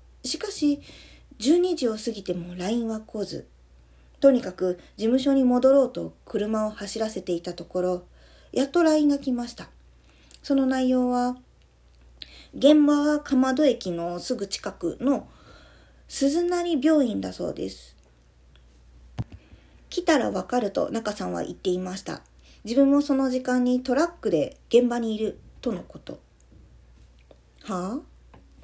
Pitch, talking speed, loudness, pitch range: 230 Hz, 255 characters per minute, -25 LUFS, 175-275 Hz